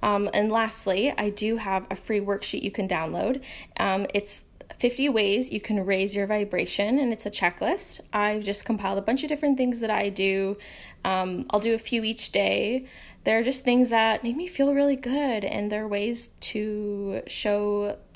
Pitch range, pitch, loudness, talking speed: 200-245 Hz, 210 Hz, -26 LUFS, 190 wpm